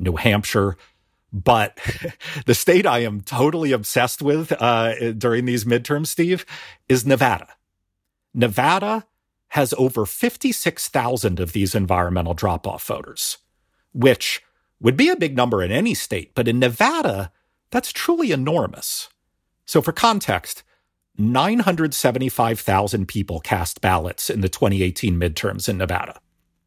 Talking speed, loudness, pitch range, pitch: 125 wpm, -20 LUFS, 95-140 Hz, 115 Hz